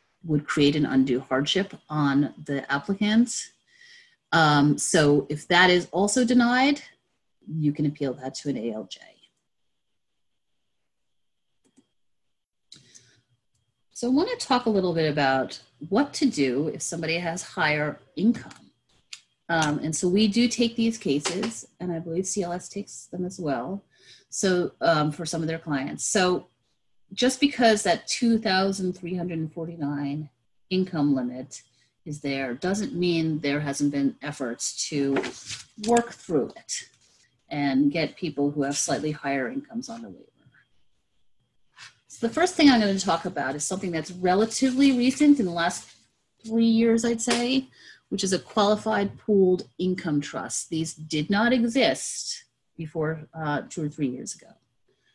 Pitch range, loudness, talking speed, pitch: 145-210 Hz, -25 LUFS, 145 wpm, 165 Hz